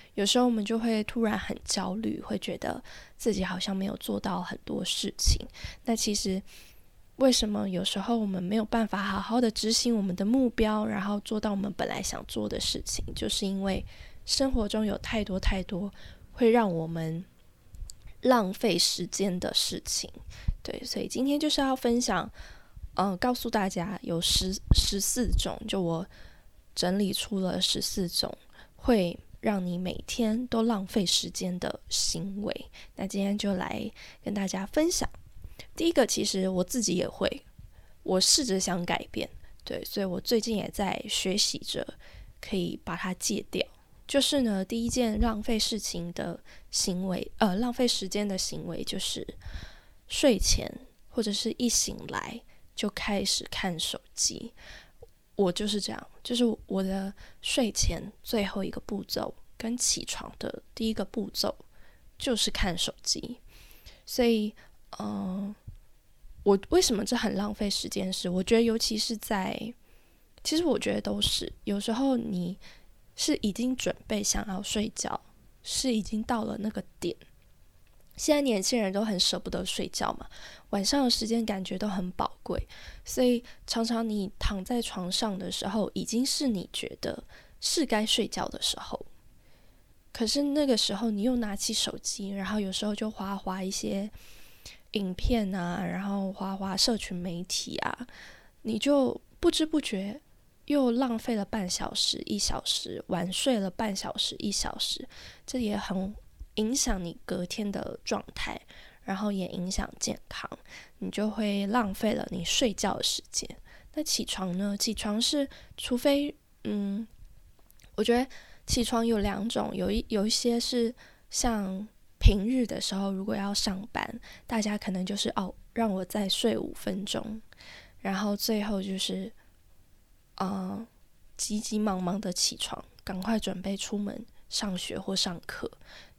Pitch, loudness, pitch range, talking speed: 210 Hz, -29 LUFS, 190-230 Hz, 225 characters per minute